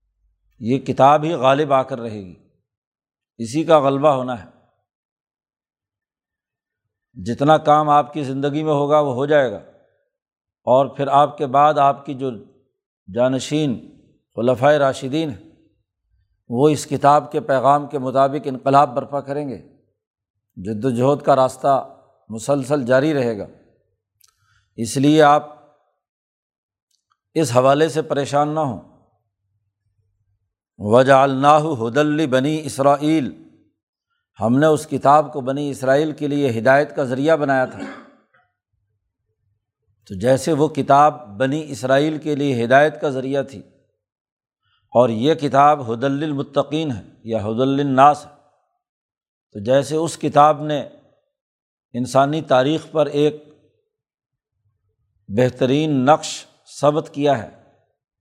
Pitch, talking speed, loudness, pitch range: 140 Hz, 120 wpm, -18 LUFS, 120-150 Hz